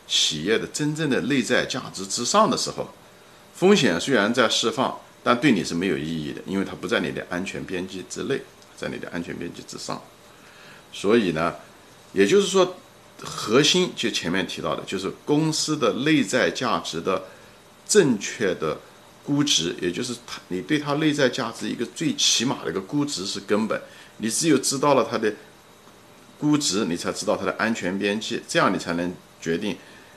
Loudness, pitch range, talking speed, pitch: -23 LUFS, 95-150 Hz, 265 characters per minute, 125 Hz